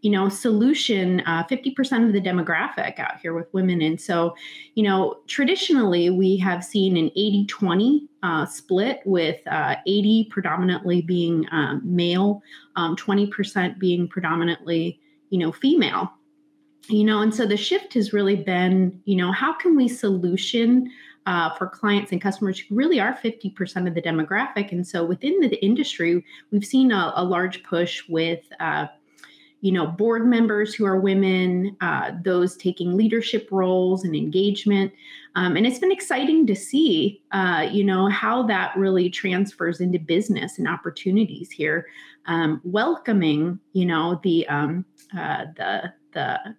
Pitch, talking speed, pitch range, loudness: 195 Hz, 155 wpm, 180-220 Hz, -22 LUFS